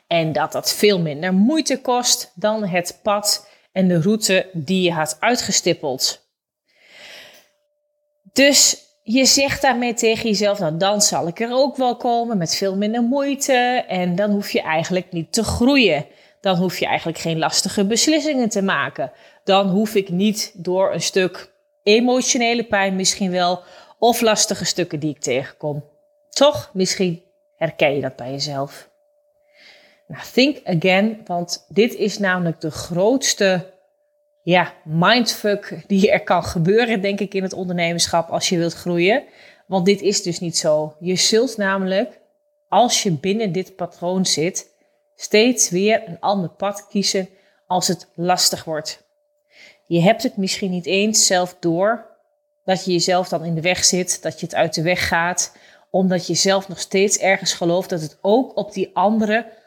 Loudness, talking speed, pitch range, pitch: -18 LUFS, 160 wpm, 180-235 Hz, 195 Hz